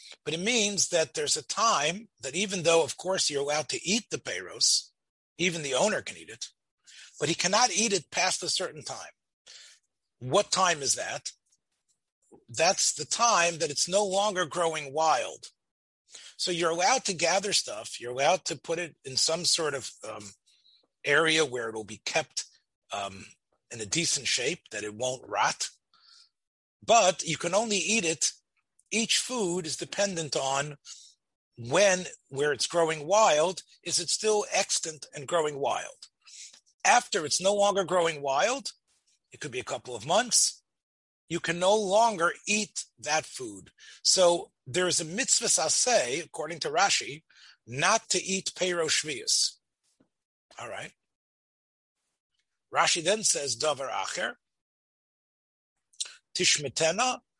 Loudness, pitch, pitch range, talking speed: -27 LUFS, 175 Hz, 150-205 Hz, 145 wpm